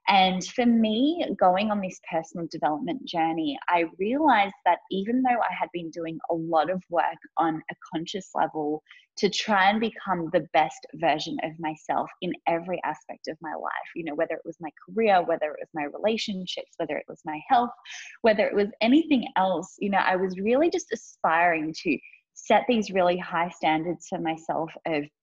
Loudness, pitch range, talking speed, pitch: -26 LUFS, 165-215 Hz, 190 wpm, 185 Hz